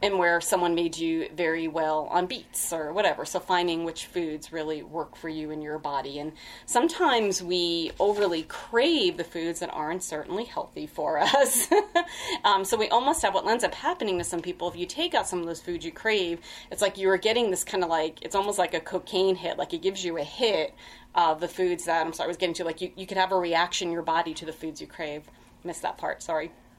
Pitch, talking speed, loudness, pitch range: 175 Hz, 240 wpm, -27 LUFS, 165-195 Hz